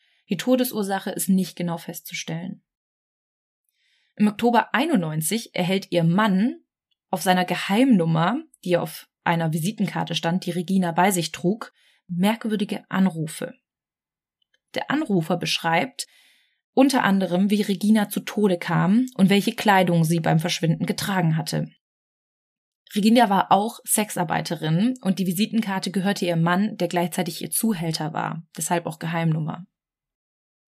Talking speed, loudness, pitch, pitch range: 125 wpm, -22 LUFS, 190 Hz, 170-215 Hz